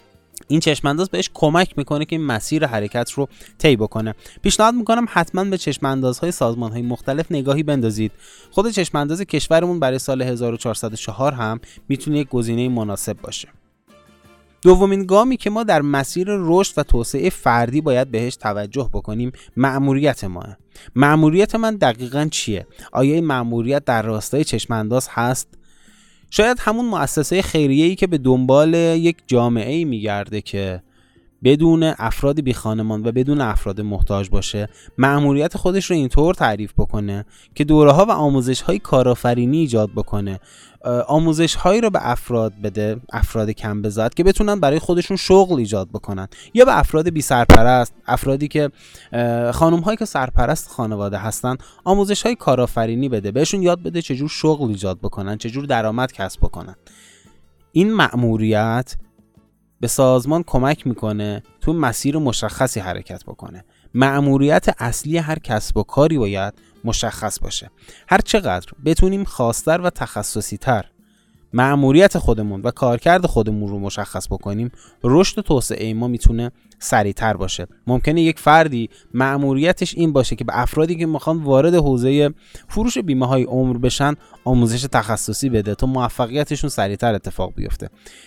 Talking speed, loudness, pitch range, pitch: 145 wpm, -18 LUFS, 110-155 Hz, 130 Hz